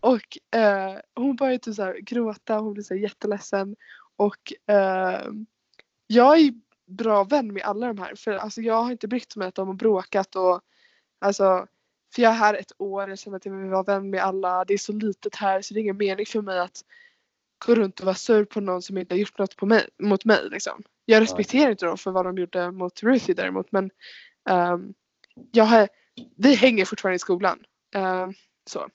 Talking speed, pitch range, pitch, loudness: 205 wpm, 190-225 Hz, 205 Hz, -23 LUFS